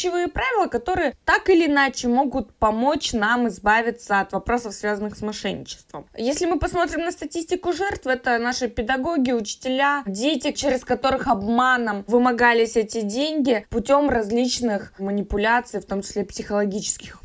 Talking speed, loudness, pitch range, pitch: 130 wpm, -22 LUFS, 220-285 Hz, 245 Hz